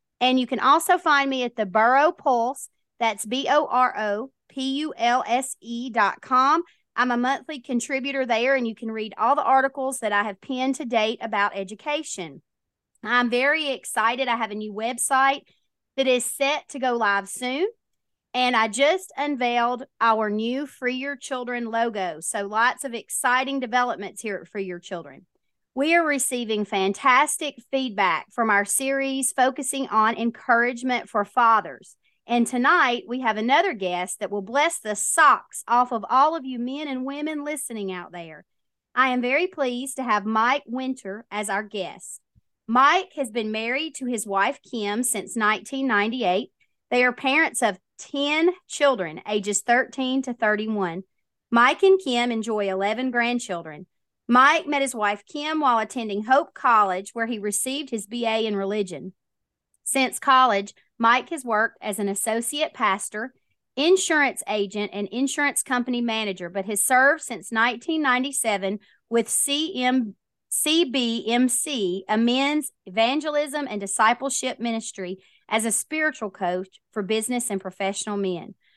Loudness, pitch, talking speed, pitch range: -23 LUFS, 240 Hz, 155 wpm, 210-270 Hz